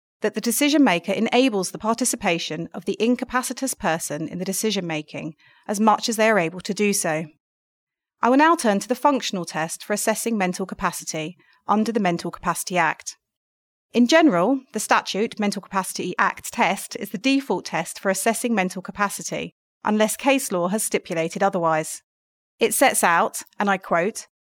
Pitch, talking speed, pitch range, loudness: 205 Hz, 170 wpm, 175-230 Hz, -22 LUFS